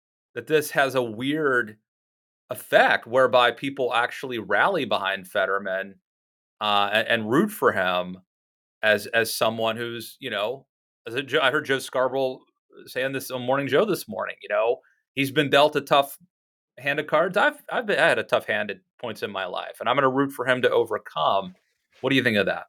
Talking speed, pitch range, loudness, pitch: 200 wpm, 100-140 Hz, -23 LUFS, 125 Hz